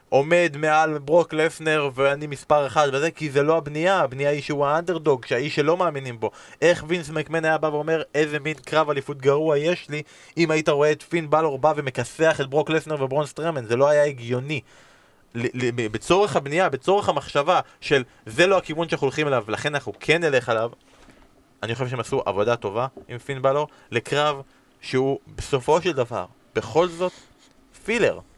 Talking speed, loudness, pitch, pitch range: 180 wpm, -23 LUFS, 150 Hz, 135-160 Hz